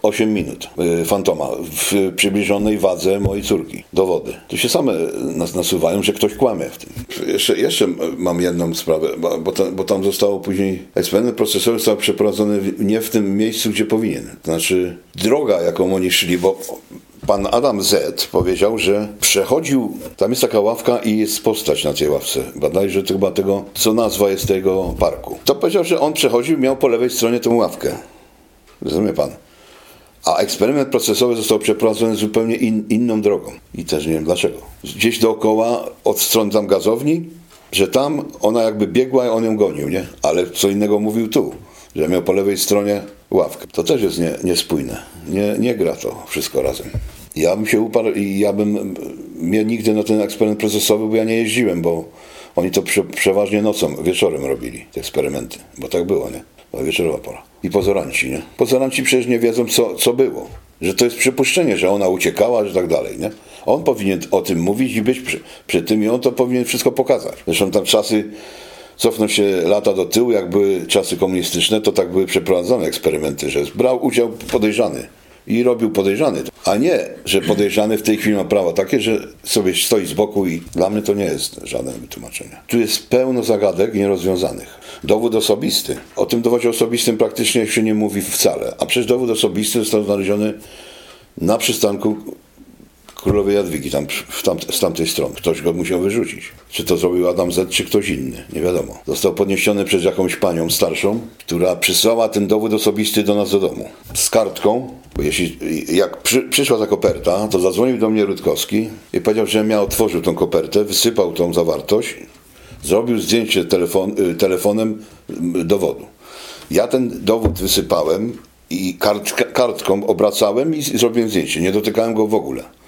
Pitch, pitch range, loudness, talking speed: 105 Hz, 95-115 Hz, -17 LUFS, 180 wpm